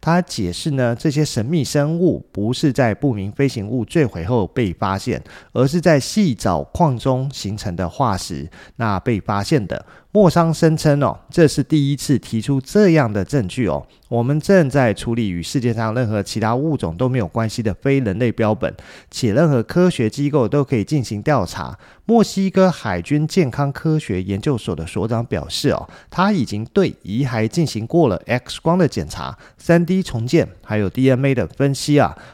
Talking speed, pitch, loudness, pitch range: 270 characters per minute, 130 Hz, -18 LUFS, 110-150 Hz